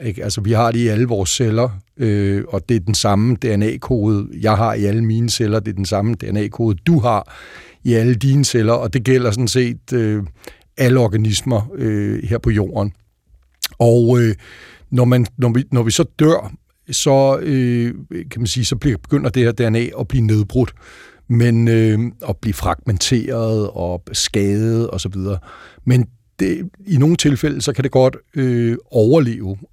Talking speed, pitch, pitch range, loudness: 180 wpm, 115 Hz, 105-125 Hz, -17 LUFS